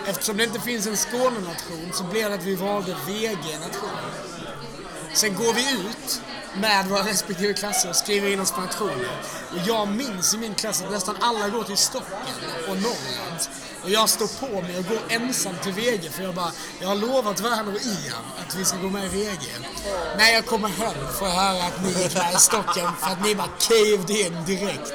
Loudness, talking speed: -23 LUFS, 210 wpm